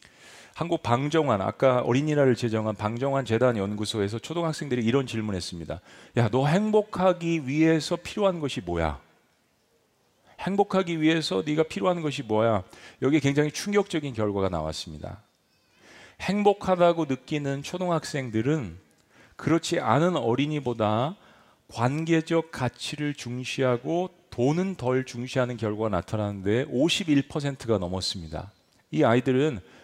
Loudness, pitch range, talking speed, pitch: -26 LUFS, 110-160 Hz, 300 characters per minute, 135 Hz